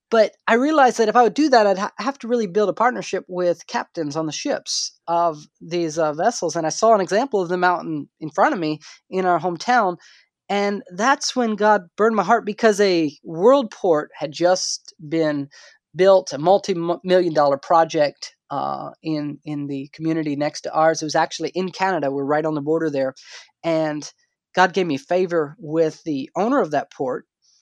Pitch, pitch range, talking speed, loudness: 180 Hz, 155-210 Hz, 195 wpm, -20 LUFS